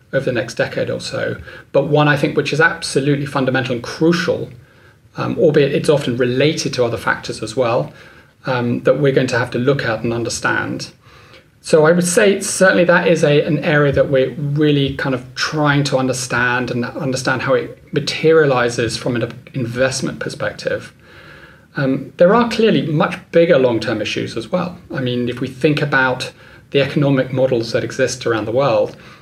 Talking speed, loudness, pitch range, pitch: 185 wpm, -16 LUFS, 125-160 Hz, 135 Hz